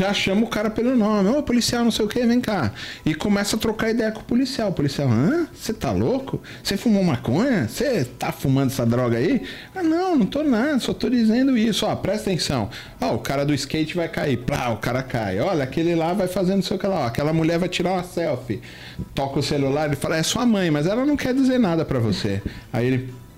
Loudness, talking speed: -22 LUFS, 250 wpm